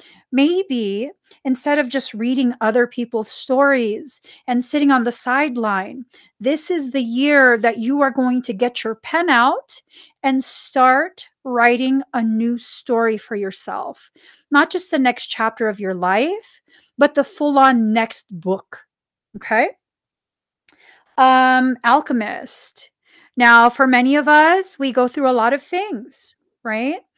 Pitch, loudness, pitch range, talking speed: 255 Hz, -17 LUFS, 235-285 Hz, 140 wpm